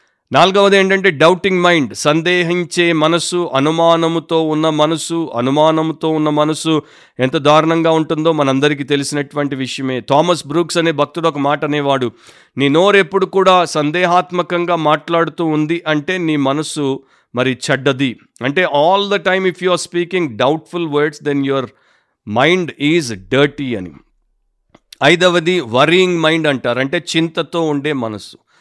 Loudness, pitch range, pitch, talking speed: -14 LUFS, 145-175 Hz, 160 Hz, 130 wpm